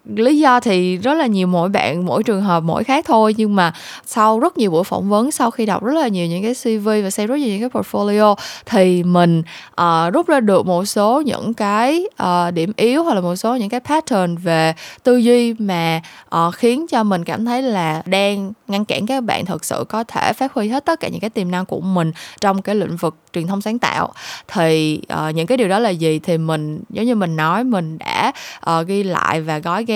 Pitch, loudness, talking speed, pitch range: 205 Hz, -17 LUFS, 240 wpm, 175-235 Hz